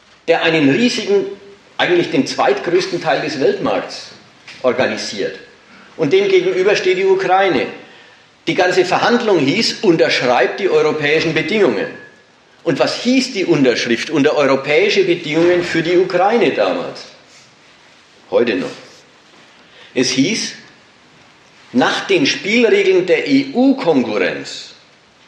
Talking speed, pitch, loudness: 105 wpm, 245 Hz, -15 LUFS